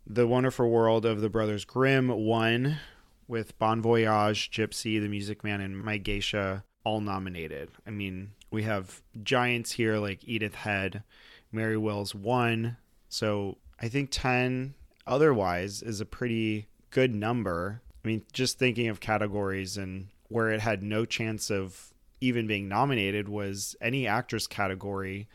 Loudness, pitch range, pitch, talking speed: -29 LUFS, 100-115 Hz, 110 Hz, 145 wpm